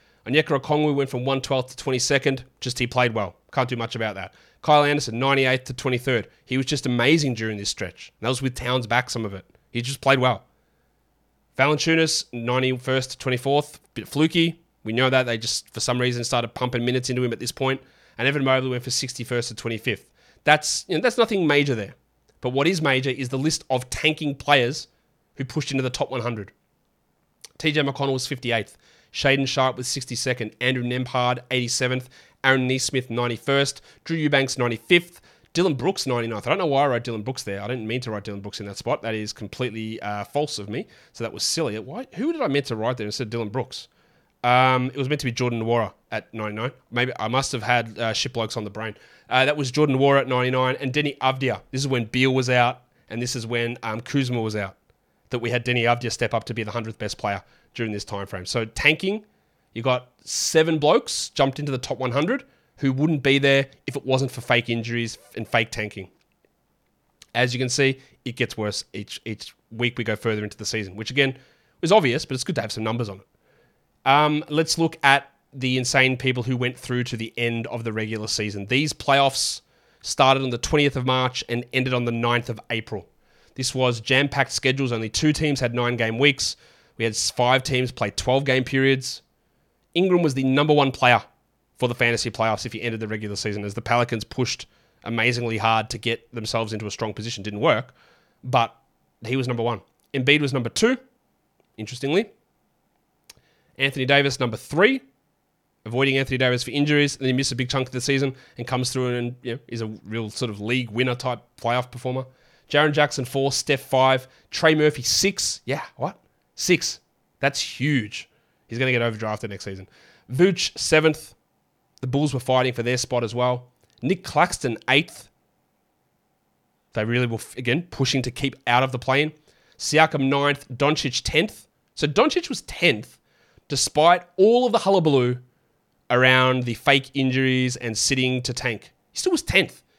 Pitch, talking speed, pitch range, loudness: 125 Hz, 200 wpm, 115-140 Hz, -23 LUFS